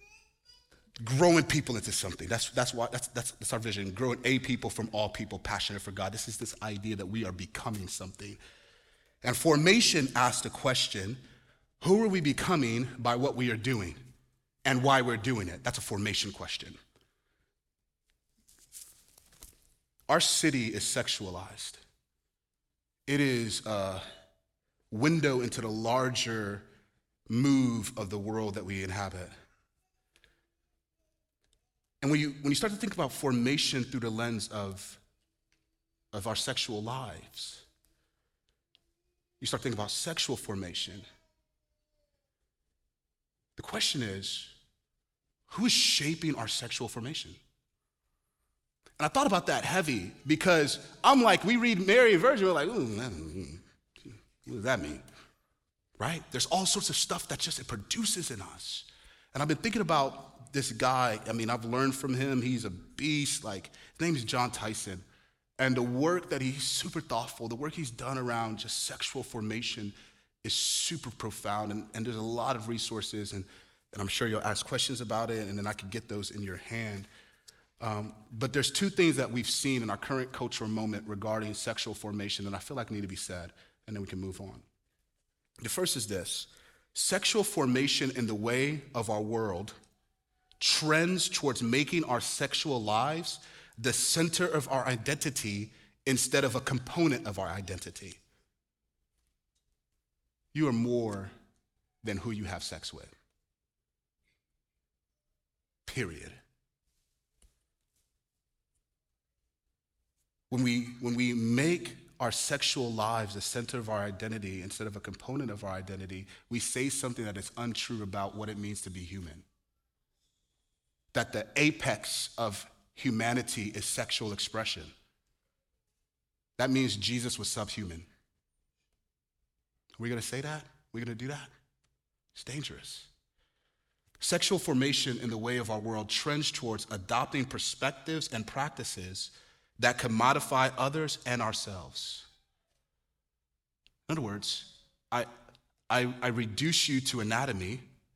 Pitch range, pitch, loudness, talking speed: 100-135 Hz, 115 Hz, -31 LUFS, 145 wpm